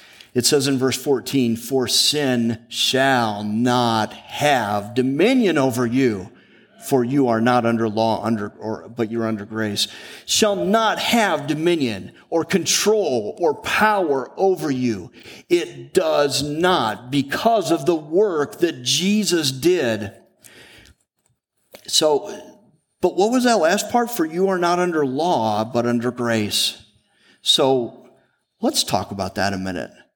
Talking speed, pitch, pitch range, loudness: 135 wpm, 130 Hz, 115-175 Hz, -19 LUFS